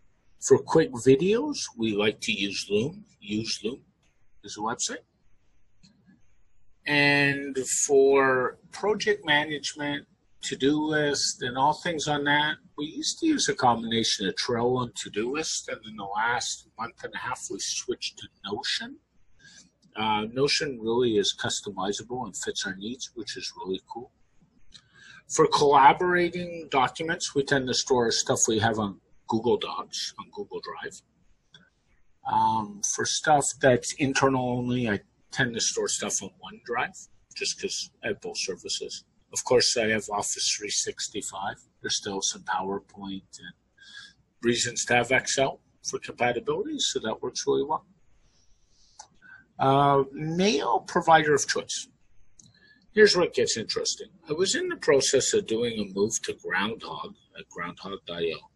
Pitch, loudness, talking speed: 165 Hz, -26 LUFS, 145 wpm